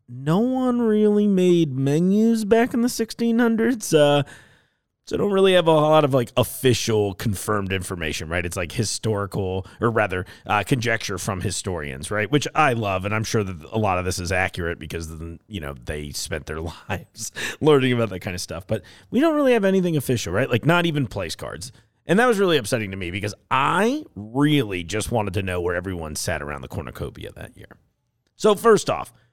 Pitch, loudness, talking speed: 115 Hz, -22 LUFS, 195 wpm